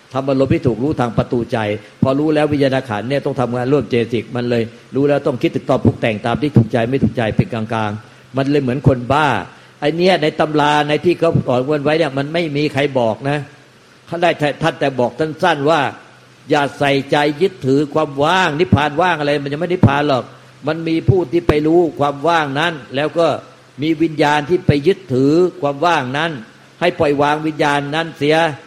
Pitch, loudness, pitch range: 145 Hz, -16 LUFS, 130-160 Hz